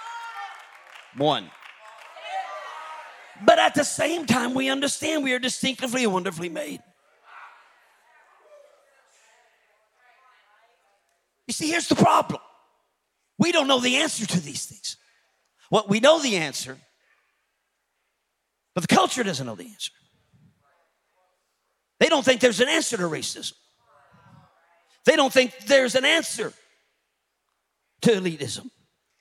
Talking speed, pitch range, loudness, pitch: 115 wpm, 215-300 Hz, -22 LUFS, 255 Hz